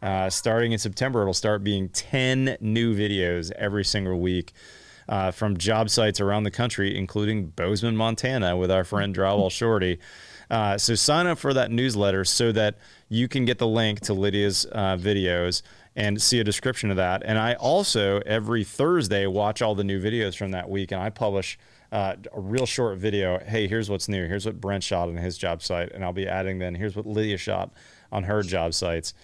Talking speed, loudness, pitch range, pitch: 200 wpm, -25 LUFS, 95-110 Hz, 105 Hz